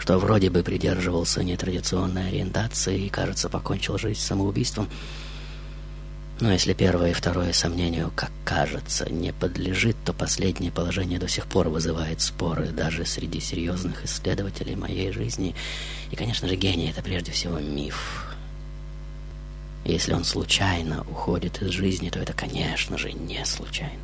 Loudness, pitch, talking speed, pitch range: -26 LUFS, 90 Hz, 140 wpm, 85-95 Hz